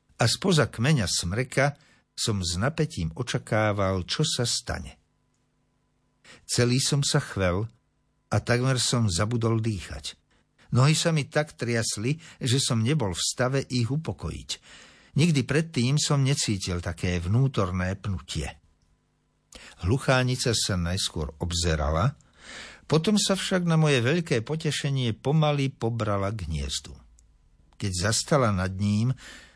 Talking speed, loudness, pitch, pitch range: 120 wpm, -26 LUFS, 120 Hz, 95-140 Hz